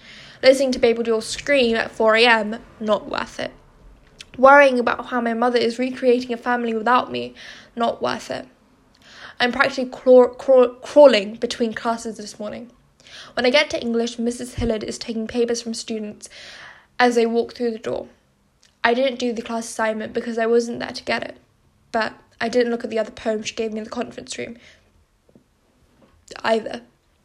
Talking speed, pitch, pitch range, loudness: 175 wpm, 235 Hz, 225-245 Hz, -20 LUFS